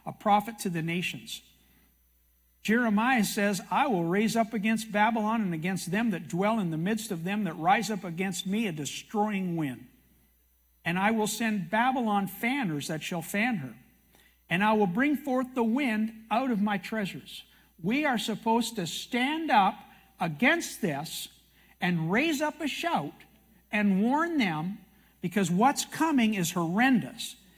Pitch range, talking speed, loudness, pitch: 180-230 Hz, 160 wpm, -28 LUFS, 205 Hz